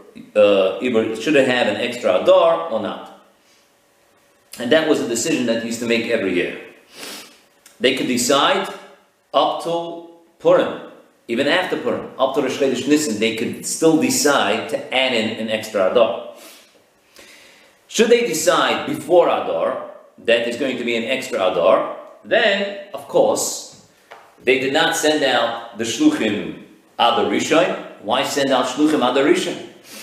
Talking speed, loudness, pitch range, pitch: 150 wpm, -18 LUFS, 115-165 Hz, 135 Hz